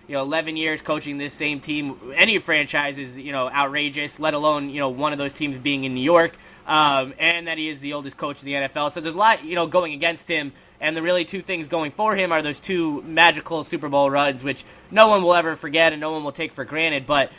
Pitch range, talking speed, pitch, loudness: 145-165 Hz, 260 wpm, 155 Hz, -21 LUFS